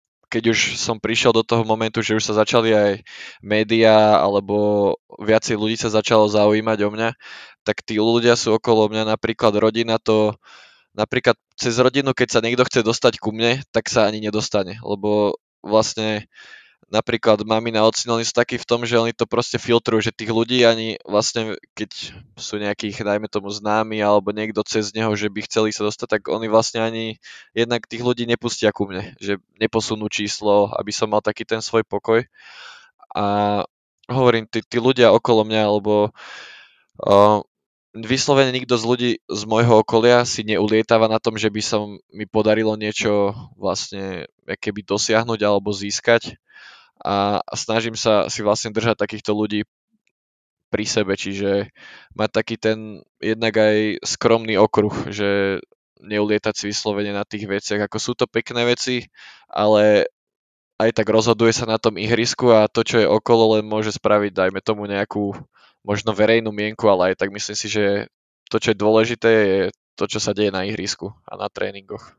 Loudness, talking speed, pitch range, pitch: -19 LUFS, 170 wpm, 105-115 Hz, 110 Hz